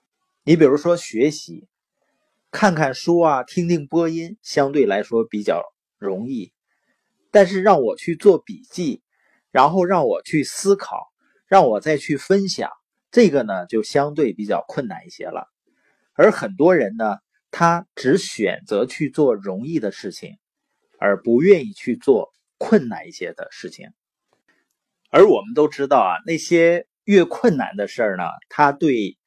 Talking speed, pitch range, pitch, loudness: 210 characters per minute, 150-200 Hz, 170 Hz, -18 LUFS